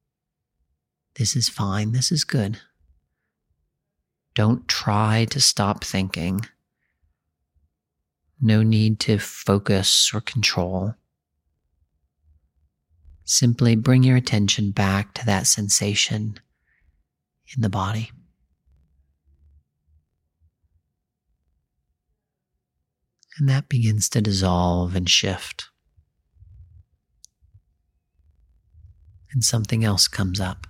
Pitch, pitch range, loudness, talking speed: 90 Hz, 75-110 Hz, -20 LUFS, 80 wpm